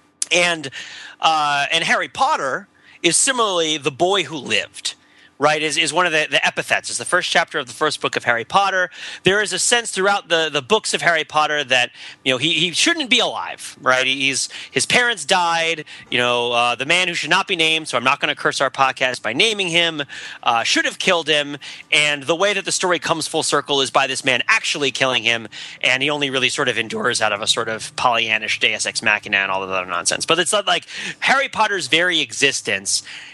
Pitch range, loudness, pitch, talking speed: 130-175 Hz, -18 LUFS, 155 Hz, 225 wpm